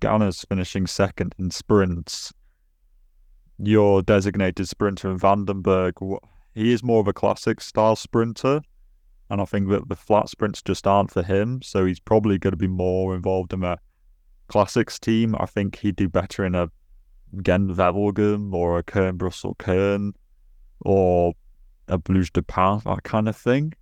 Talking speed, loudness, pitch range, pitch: 160 wpm, -22 LUFS, 90-105 Hz, 95 Hz